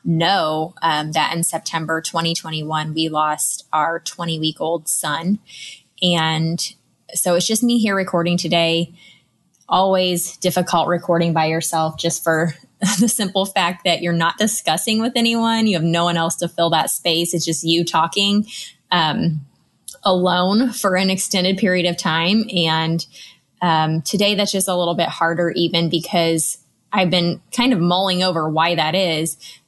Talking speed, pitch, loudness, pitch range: 160 wpm, 170 Hz, -18 LUFS, 160-190 Hz